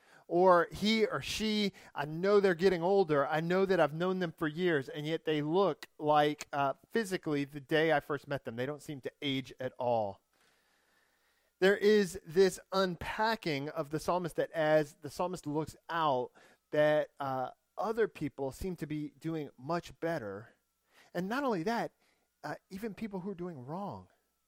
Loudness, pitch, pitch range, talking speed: -33 LUFS, 160 Hz, 150-190 Hz, 175 wpm